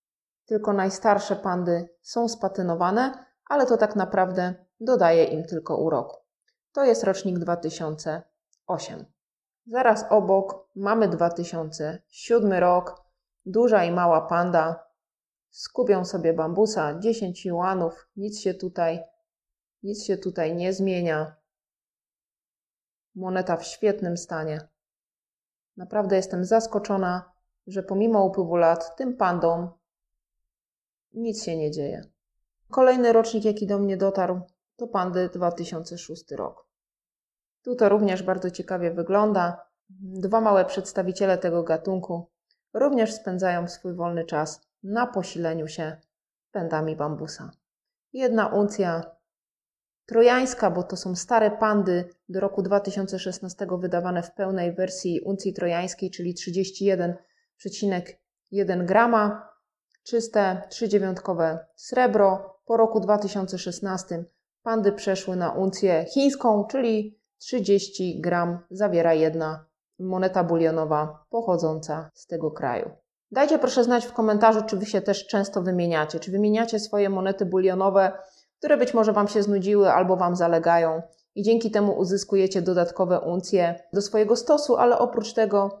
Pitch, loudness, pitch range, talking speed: 190 Hz, -24 LUFS, 175-210 Hz, 115 wpm